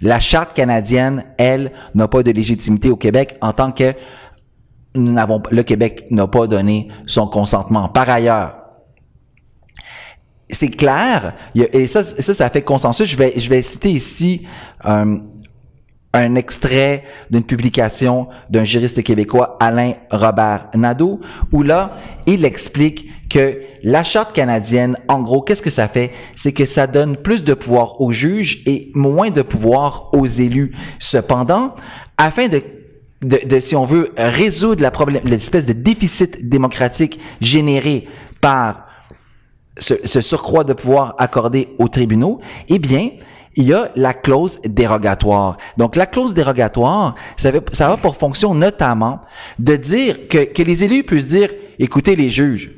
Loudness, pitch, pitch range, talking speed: -14 LUFS, 130 Hz, 120-150 Hz, 150 wpm